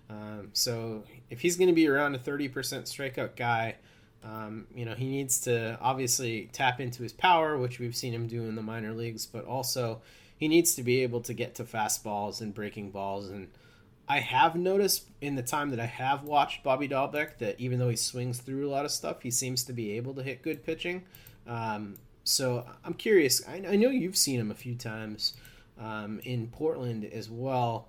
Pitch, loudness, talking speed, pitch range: 120 Hz, -30 LUFS, 205 wpm, 110-135 Hz